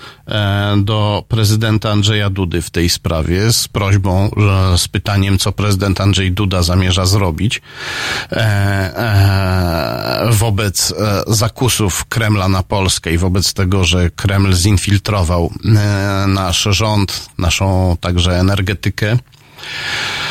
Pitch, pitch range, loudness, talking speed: 100 Hz, 95-105 Hz, -14 LUFS, 100 wpm